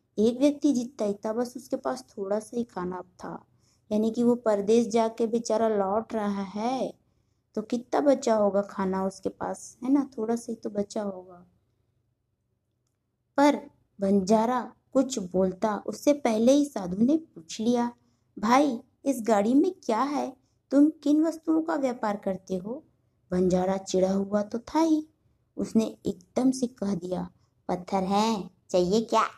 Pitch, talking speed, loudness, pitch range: 220 Hz, 155 wpm, -27 LUFS, 195-255 Hz